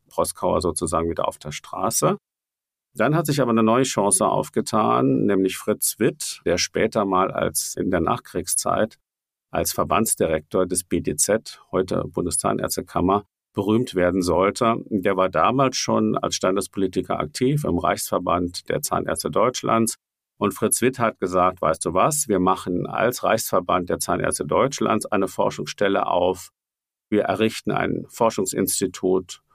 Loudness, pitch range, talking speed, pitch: -22 LUFS, 95-115 Hz, 135 wpm, 100 Hz